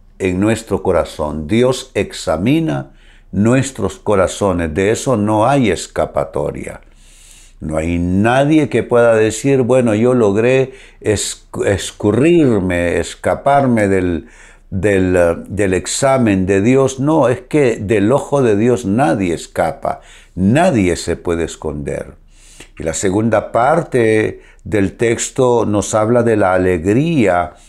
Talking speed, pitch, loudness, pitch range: 115 wpm, 110 Hz, -15 LUFS, 95-130 Hz